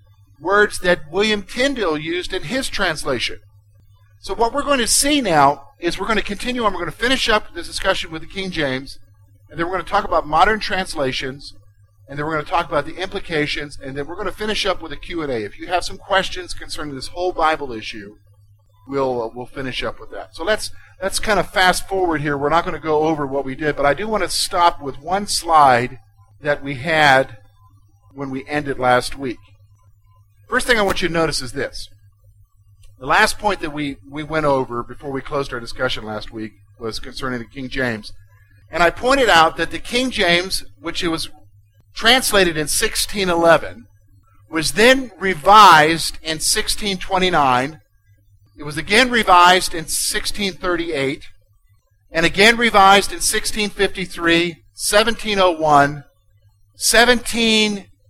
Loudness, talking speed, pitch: -17 LUFS, 180 wpm, 155 Hz